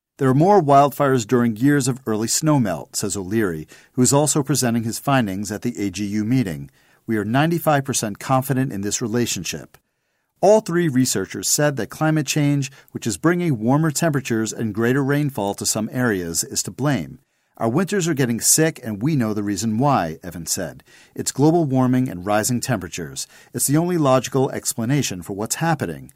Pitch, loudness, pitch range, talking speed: 125 Hz, -20 LUFS, 110-145 Hz, 175 wpm